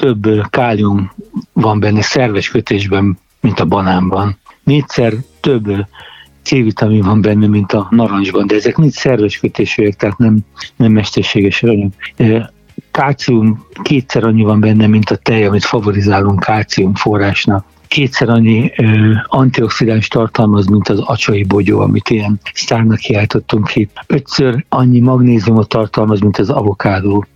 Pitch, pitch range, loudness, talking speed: 110 Hz, 100-115 Hz, -12 LUFS, 130 wpm